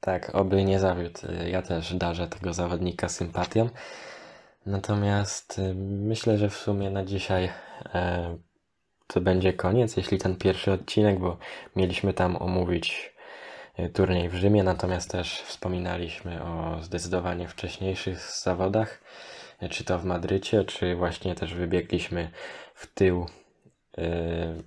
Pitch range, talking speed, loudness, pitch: 85-95 Hz, 115 wpm, -28 LUFS, 90 Hz